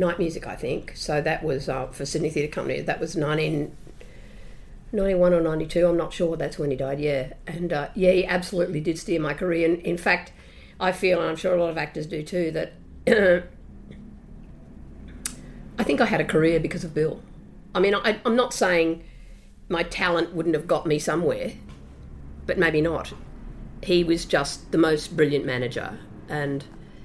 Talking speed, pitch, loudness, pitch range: 180 wpm, 165 Hz, -24 LUFS, 145-180 Hz